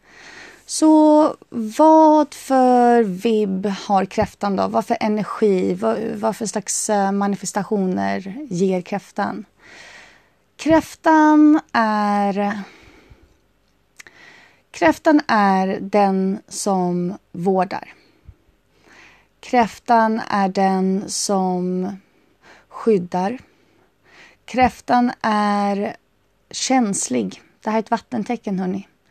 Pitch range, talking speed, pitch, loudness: 195-245 Hz, 80 wpm, 210 Hz, -18 LUFS